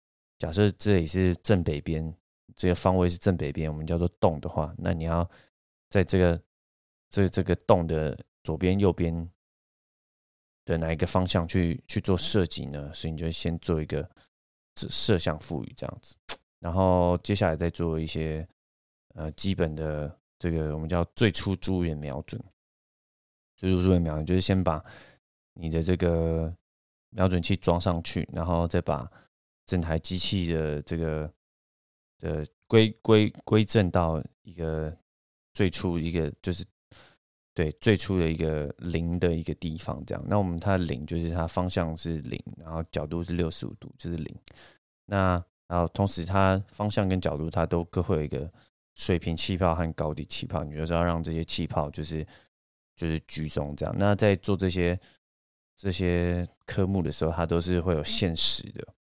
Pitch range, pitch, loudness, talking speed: 80-95 Hz, 85 Hz, -28 LUFS, 240 characters per minute